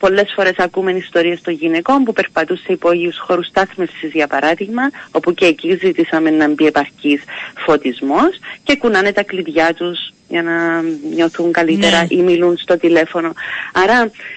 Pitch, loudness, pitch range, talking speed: 175 Hz, -15 LUFS, 165-190 Hz, 150 wpm